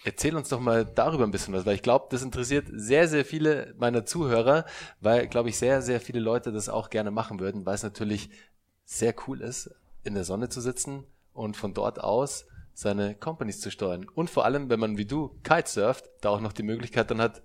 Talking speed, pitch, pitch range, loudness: 220 wpm, 115 Hz, 105-130 Hz, -28 LUFS